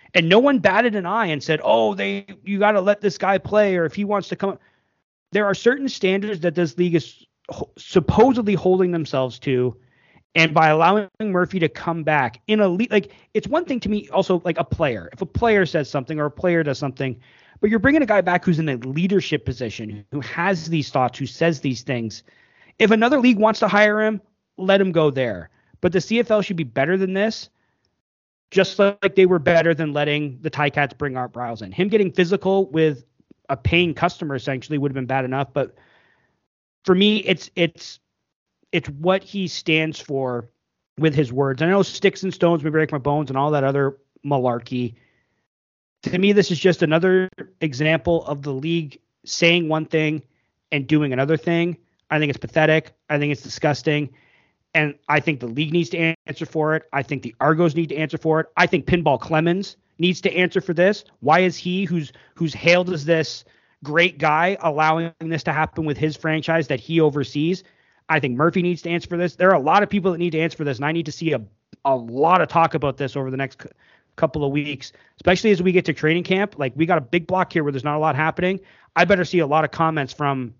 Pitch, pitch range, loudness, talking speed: 160 Hz, 145-185 Hz, -20 LUFS, 220 wpm